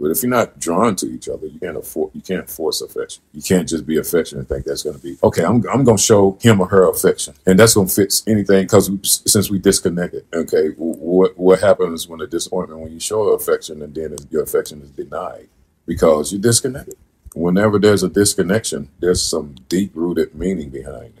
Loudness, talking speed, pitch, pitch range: -16 LUFS, 220 wpm, 100 Hz, 90-120 Hz